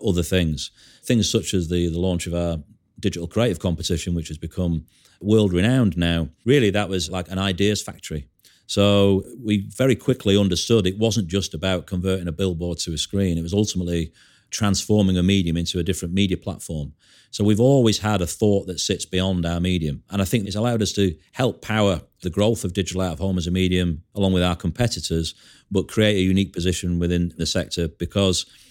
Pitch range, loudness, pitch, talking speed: 85-105 Hz, -22 LUFS, 95 Hz, 200 wpm